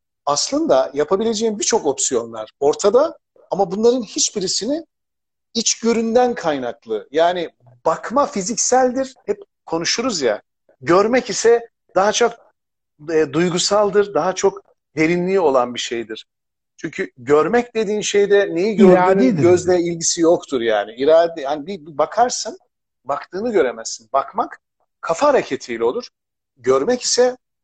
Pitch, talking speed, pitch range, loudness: 195 Hz, 110 wpm, 155-235 Hz, -18 LUFS